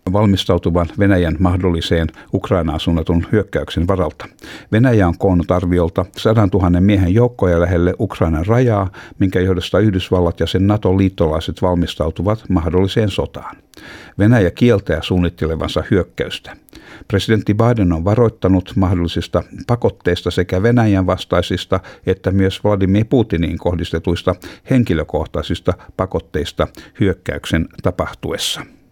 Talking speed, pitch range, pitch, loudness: 100 wpm, 85-105 Hz, 95 Hz, -16 LUFS